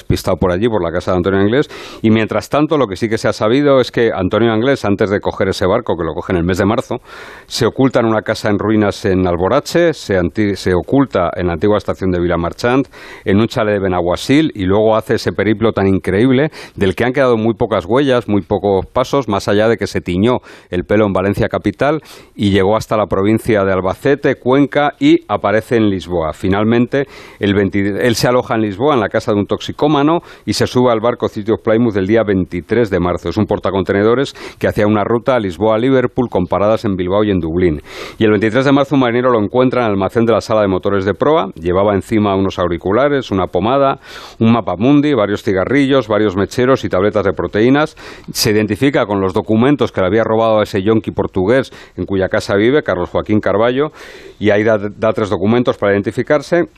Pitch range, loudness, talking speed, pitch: 100-125 Hz, -14 LUFS, 220 wpm, 110 Hz